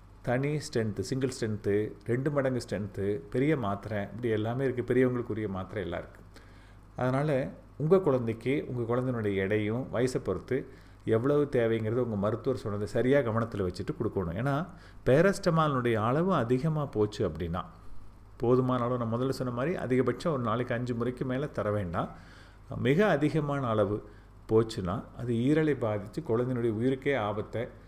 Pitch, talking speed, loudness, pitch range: 120 Hz, 135 wpm, -30 LUFS, 105-130 Hz